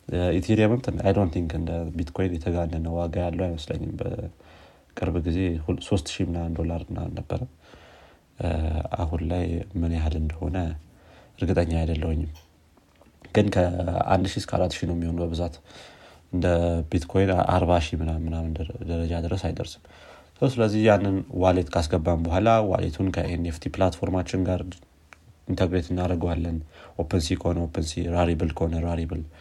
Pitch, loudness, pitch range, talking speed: 85 Hz, -26 LUFS, 80-95 Hz, 120 wpm